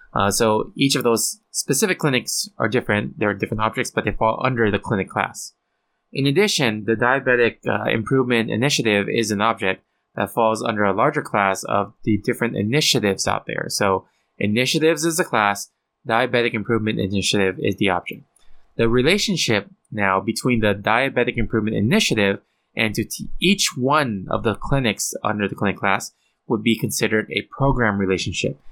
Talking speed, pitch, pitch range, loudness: 165 wpm, 115 Hz, 105-130 Hz, -20 LUFS